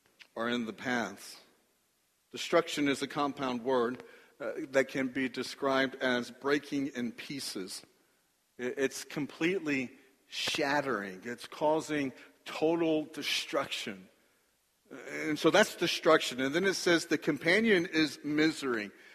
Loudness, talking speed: -31 LUFS, 115 wpm